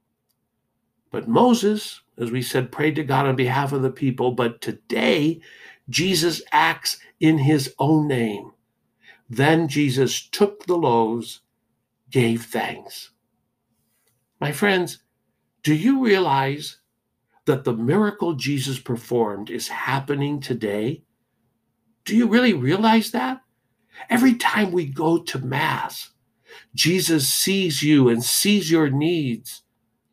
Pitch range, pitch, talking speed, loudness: 125-175 Hz, 145 Hz, 120 wpm, -21 LUFS